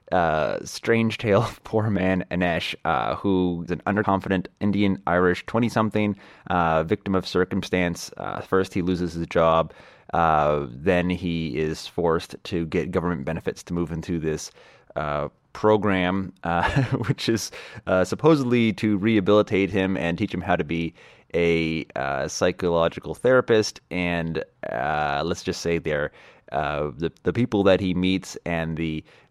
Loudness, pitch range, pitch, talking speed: -24 LUFS, 85-105 Hz, 90 Hz, 150 wpm